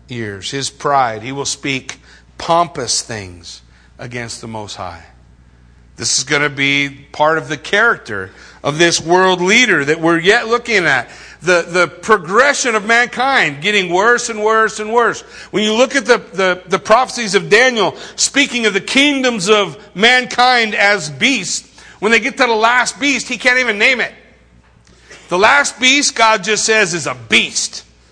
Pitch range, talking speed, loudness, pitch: 140-235 Hz, 170 wpm, -13 LUFS, 195 Hz